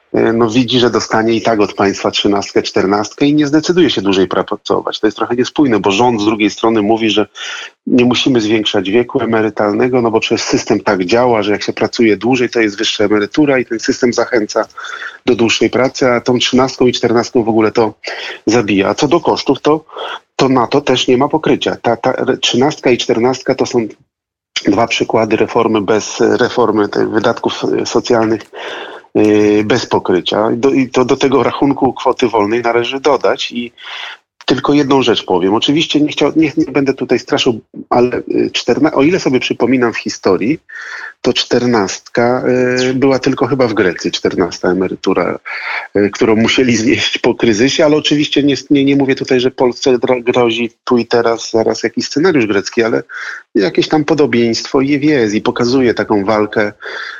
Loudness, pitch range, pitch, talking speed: -13 LUFS, 110-135 Hz, 120 Hz, 170 wpm